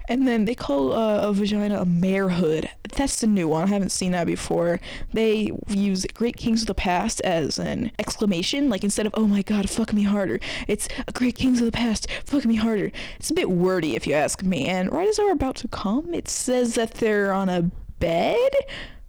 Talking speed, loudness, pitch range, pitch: 215 wpm, -23 LUFS, 190-240 Hz, 210 Hz